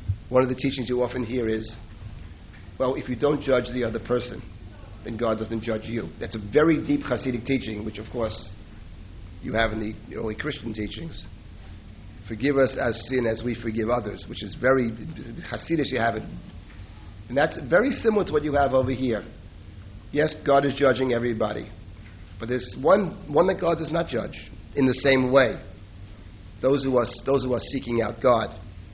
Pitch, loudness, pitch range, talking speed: 115 Hz, -25 LUFS, 100-130 Hz, 185 wpm